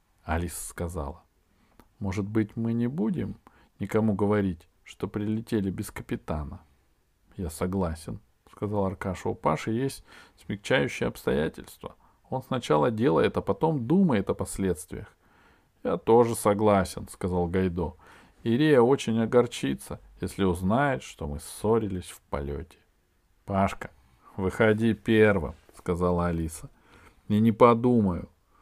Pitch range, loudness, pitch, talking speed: 90-110 Hz, -27 LUFS, 95 Hz, 110 wpm